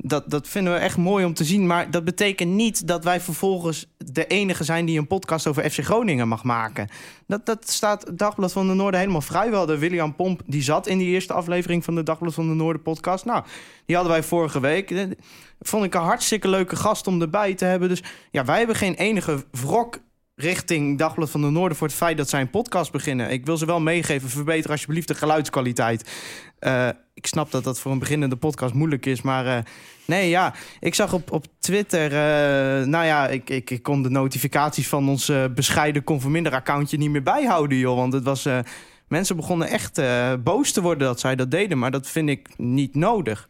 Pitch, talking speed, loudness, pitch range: 160 Hz, 220 wpm, -22 LUFS, 140-180 Hz